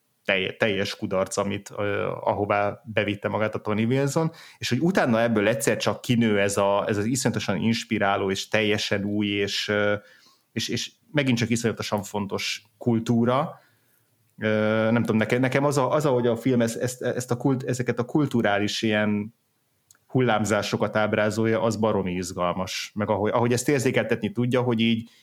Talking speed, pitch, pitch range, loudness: 150 wpm, 110 Hz, 105-120 Hz, -24 LUFS